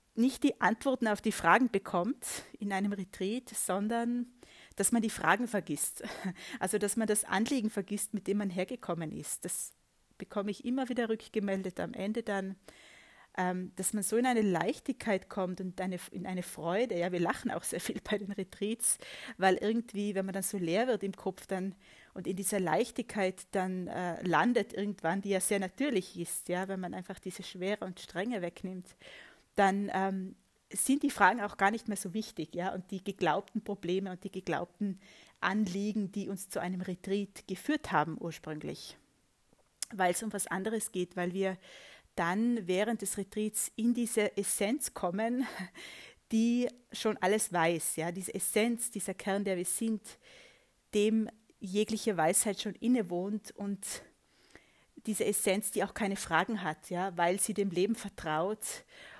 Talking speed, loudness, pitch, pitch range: 170 wpm, -33 LUFS, 200 Hz, 185-220 Hz